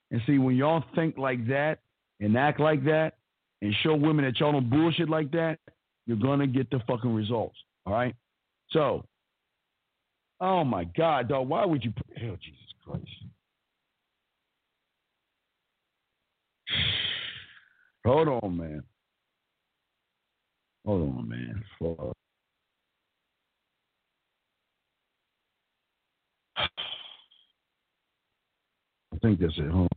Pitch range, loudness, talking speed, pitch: 105-155 Hz, -28 LUFS, 105 wpm, 130 Hz